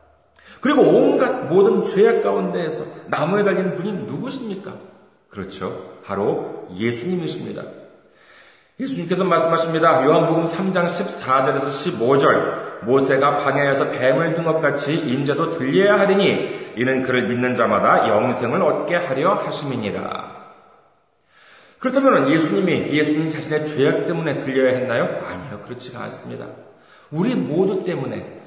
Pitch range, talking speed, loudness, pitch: 135-195 Hz, 305 characters per minute, -19 LUFS, 165 Hz